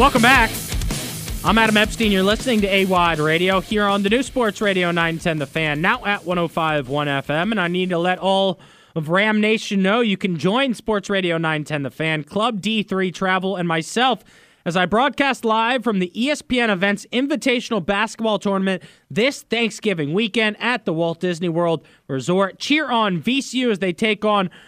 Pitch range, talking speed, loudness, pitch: 175-225 Hz, 180 wpm, -19 LUFS, 200 Hz